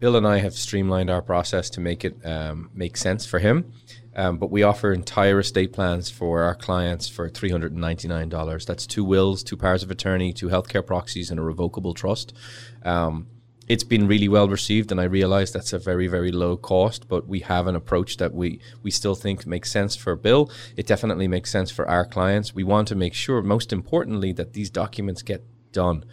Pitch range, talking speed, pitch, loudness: 90-105 Hz, 215 wpm, 95 Hz, -23 LUFS